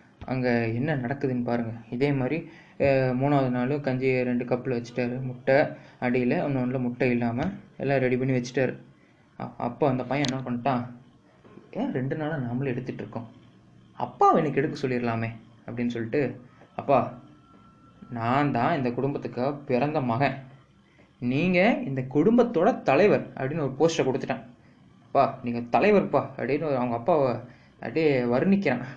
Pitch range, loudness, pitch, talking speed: 120-140 Hz, -26 LUFS, 130 Hz, 130 wpm